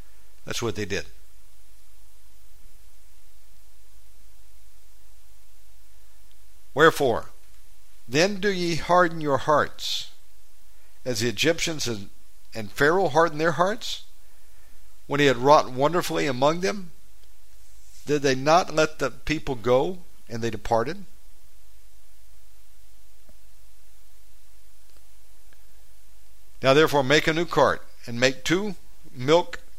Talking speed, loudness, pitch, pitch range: 95 wpm, -23 LUFS, 110 Hz, 95-150 Hz